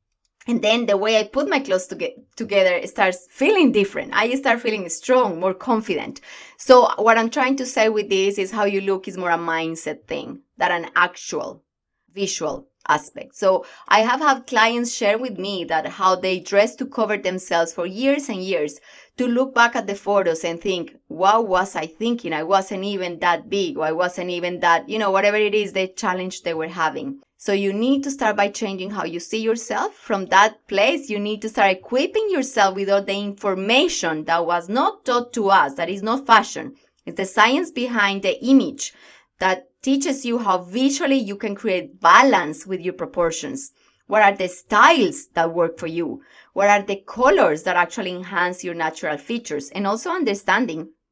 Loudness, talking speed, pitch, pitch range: -20 LUFS, 195 wpm, 200 Hz, 185-235 Hz